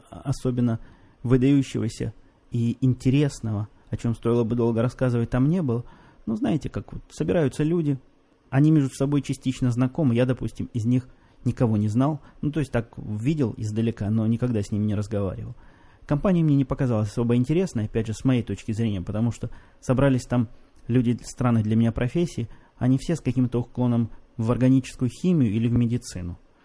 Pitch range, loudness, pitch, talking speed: 115-130 Hz, -24 LUFS, 120 Hz, 170 wpm